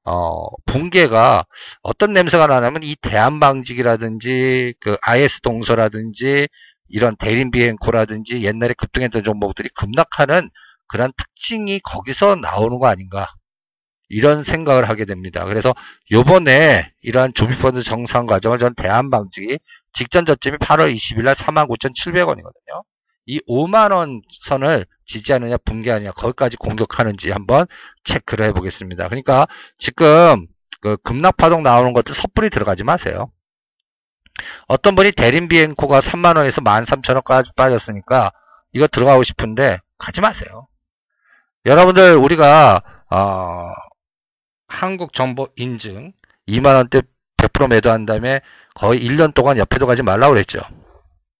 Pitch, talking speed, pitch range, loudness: 125 Hz, 295 characters per minute, 110-145 Hz, -15 LUFS